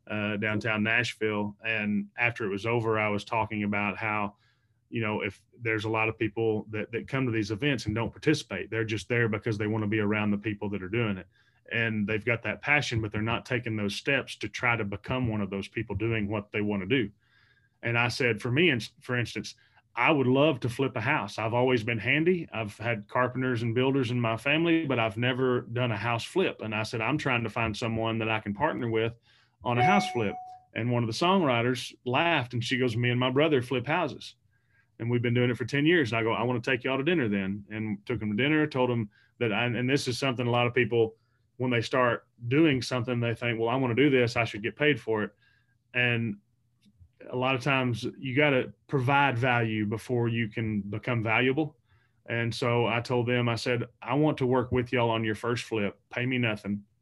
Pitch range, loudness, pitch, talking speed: 110-125 Hz, -28 LUFS, 120 Hz, 235 wpm